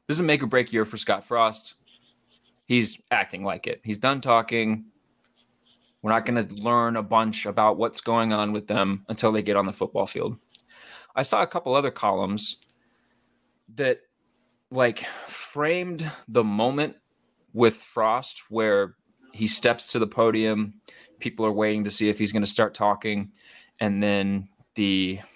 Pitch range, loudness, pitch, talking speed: 105-120 Hz, -25 LUFS, 110 Hz, 165 wpm